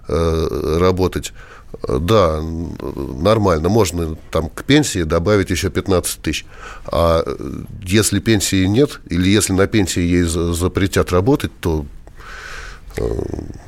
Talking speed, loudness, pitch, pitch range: 100 wpm, -17 LUFS, 90 Hz, 85-100 Hz